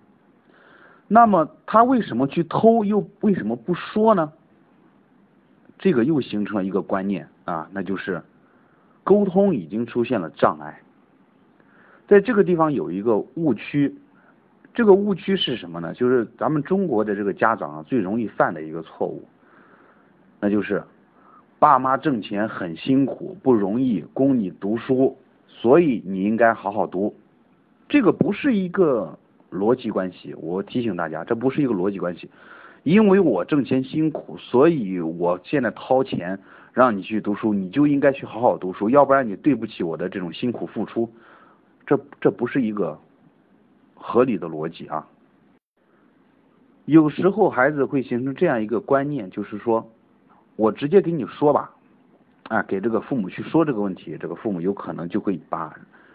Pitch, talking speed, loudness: 130 Hz, 245 characters per minute, -21 LUFS